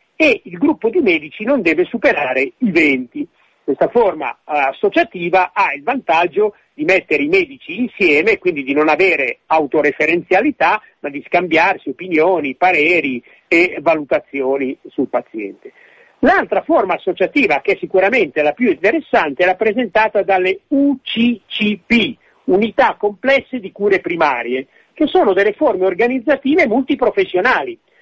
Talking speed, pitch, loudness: 125 wpm, 235 Hz, -15 LUFS